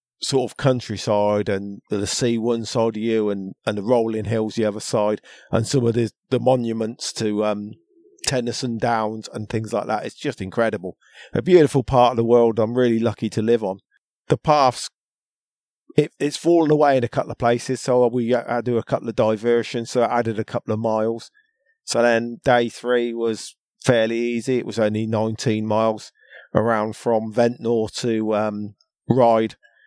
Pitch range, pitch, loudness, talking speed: 110-125 Hz, 115 Hz, -21 LUFS, 185 wpm